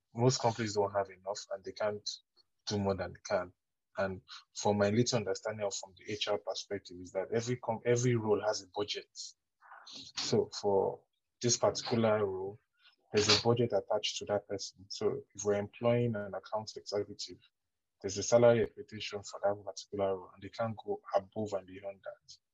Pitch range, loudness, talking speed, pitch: 100-115 Hz, -34 LUFS, 180 wpm, 105 Hz